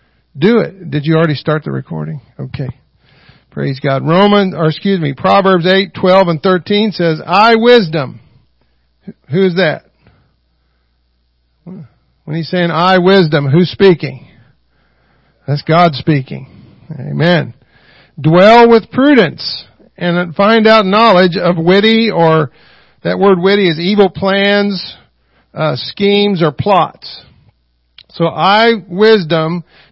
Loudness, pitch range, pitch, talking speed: -11 LUFS, 145-195 Hz, 170 Hz, 120 wpm